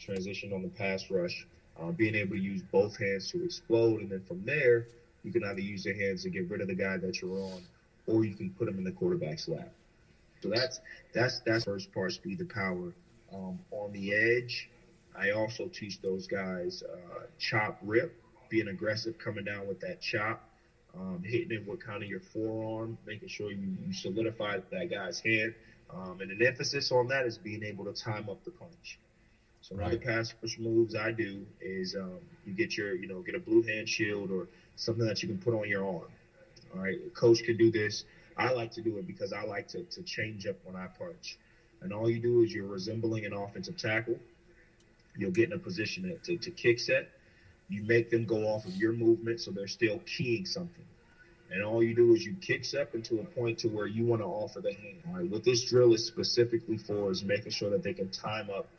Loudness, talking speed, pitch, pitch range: -33 LUFS, 225 wpm, 115 Hz, 105-170 Hz